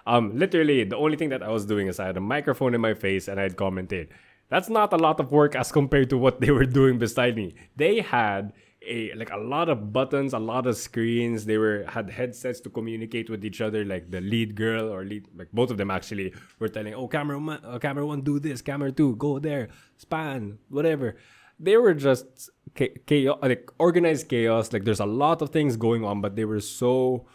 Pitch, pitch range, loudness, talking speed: 120 Hz, 110-140 Hz, -25 LUFS, 225 wpm